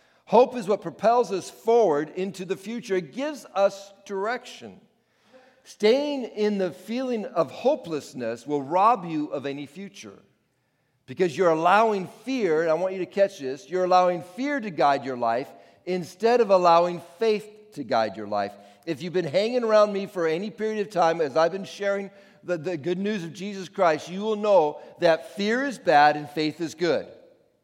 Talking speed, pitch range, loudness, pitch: 180 wpm, 160-215 Hz, -24 LUFS, 185 Hz